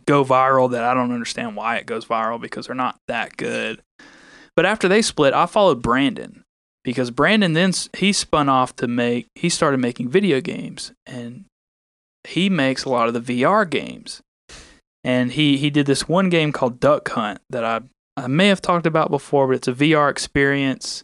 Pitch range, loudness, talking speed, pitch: 125-165 Hz, -19 LUFS, 190 wpm, 135 Hz